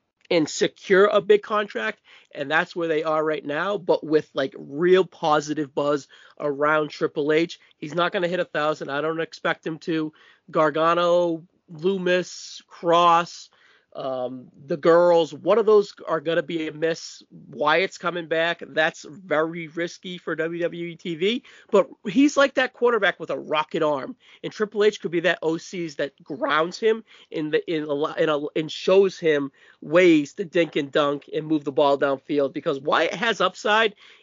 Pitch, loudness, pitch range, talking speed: 165 Hz, -23 LUFS, 155-190 Hz, 180 wpm